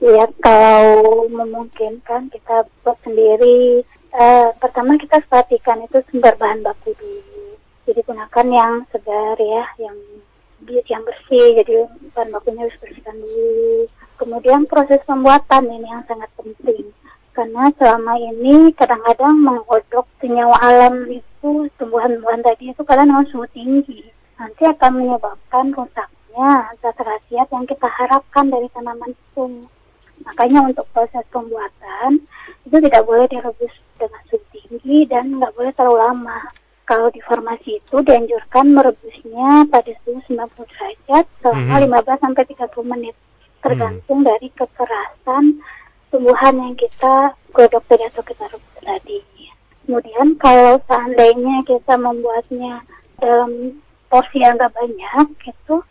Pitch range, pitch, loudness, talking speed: 235-275 Hz, 245 Hz, -14 LUFS, 125 wpm